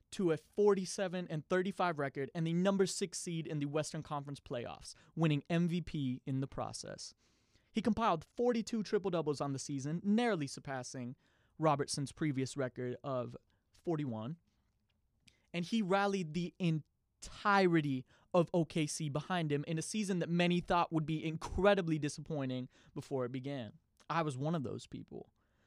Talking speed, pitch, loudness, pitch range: 150 wpm, 160 Hz, -36 LUFS, 140-180 Hz